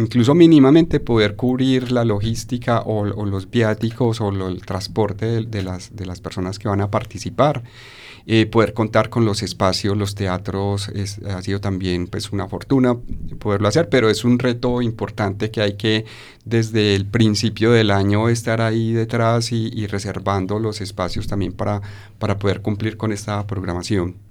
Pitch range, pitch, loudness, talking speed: 100-115 Hz, 105 Hz, -19 LUFS, 175 wpm